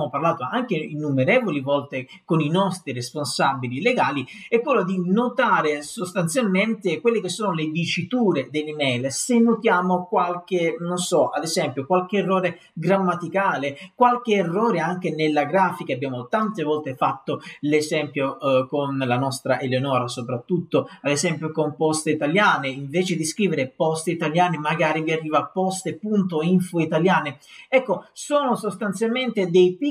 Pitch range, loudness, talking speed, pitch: 145-190 Hz, -22 LUFS, 130 wpm, 170 Hz